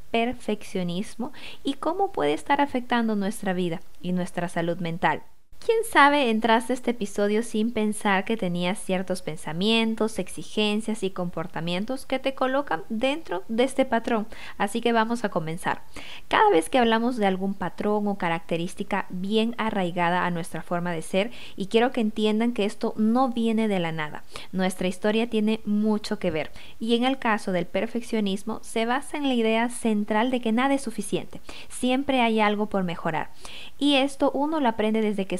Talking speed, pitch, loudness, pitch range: 170 wpm, 215 Hz, -25 LUFS, 185-235 Hz